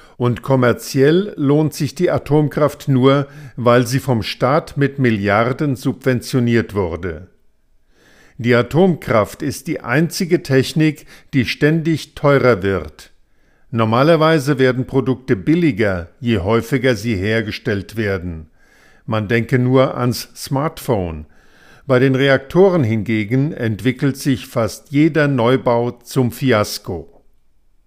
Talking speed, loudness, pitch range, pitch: 110 wpm, -17 LUFS, 115-145 Hz, 130 Hz